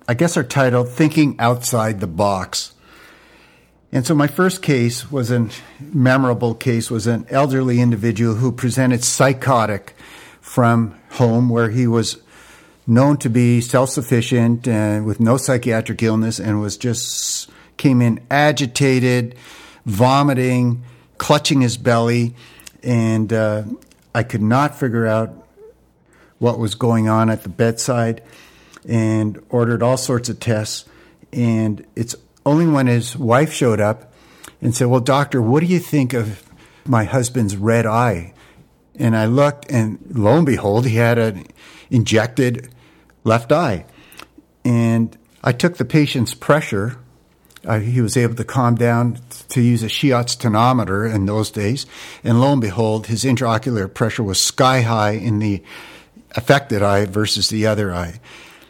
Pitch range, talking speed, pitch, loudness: 110-130 Hz, 145 wpm, 120 Hz, -17 LUFS